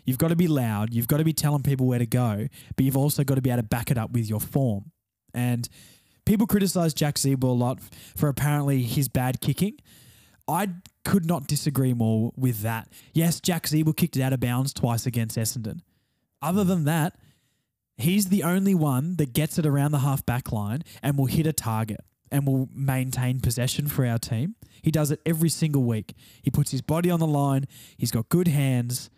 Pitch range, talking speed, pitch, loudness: 120-155 Hz, 210 wpm, 135 Hz, -25 LUFS